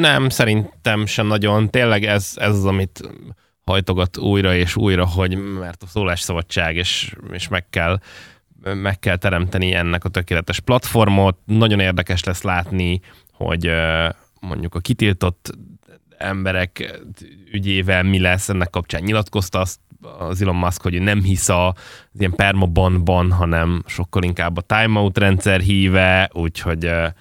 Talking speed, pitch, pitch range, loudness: 140 wpm, 95 Hz, 90-100 Hz, -18 LUFS